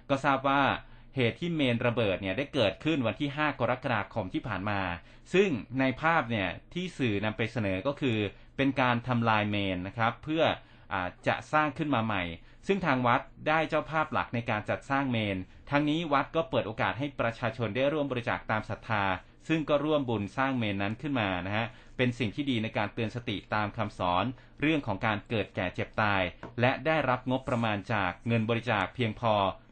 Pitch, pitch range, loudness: 120 Hz, 105-140 Hz, -30 LUFS